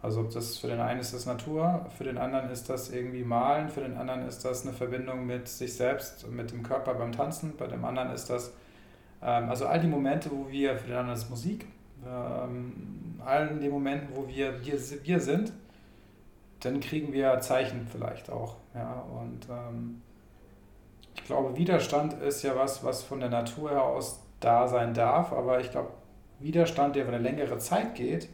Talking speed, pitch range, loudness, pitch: 195 wpm, 120-140 Hz, -31 LUFS, 125 Hz